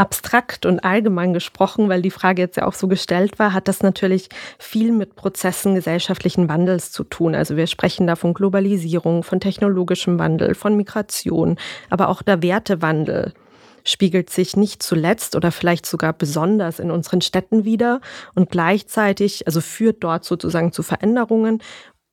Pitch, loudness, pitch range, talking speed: 185 Hz, -19 LUFS, 175-205 Hz, 155 wpm